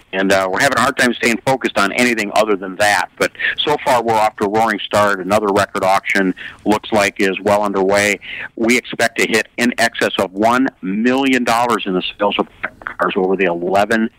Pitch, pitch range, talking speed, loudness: 105 Hz, 95-115 Hz, 210 wpm, -16 LUFS